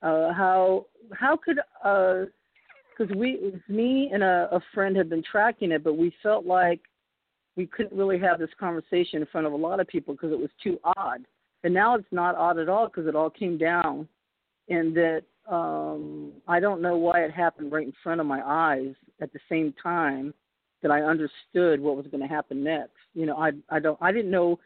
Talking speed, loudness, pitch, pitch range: 215 wpm, -26 LUFS, 170 Hz, 155-185 Hz